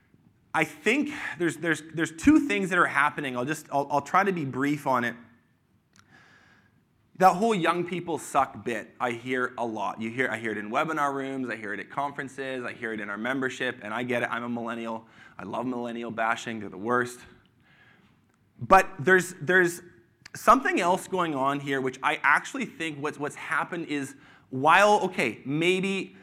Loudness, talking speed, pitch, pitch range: -26 LUFS, 190 wpm, 140 Hz, 120-170 Hz